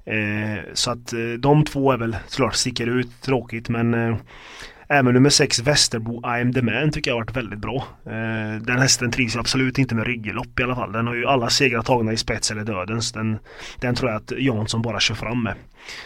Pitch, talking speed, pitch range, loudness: 120 Hz, 220 wpm, 115-130 Hz, -21 LUFS